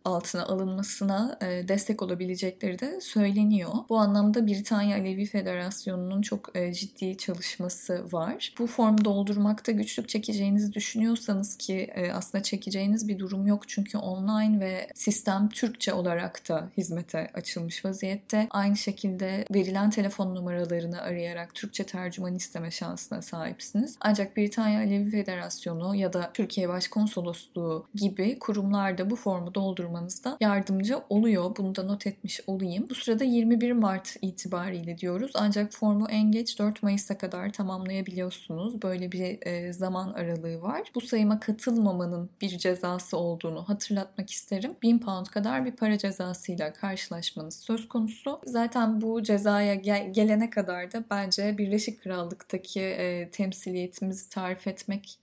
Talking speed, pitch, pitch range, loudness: 130 wpm, 200 Hz, 185-215 Hz, -29 LUFS